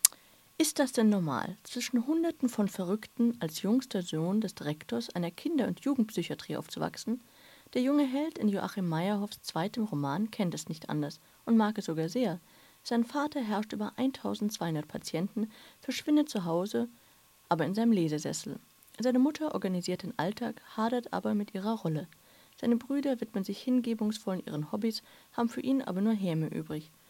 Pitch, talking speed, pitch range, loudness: 215 Hz, 160 wpm, 180-245 Hz, -32 LUFS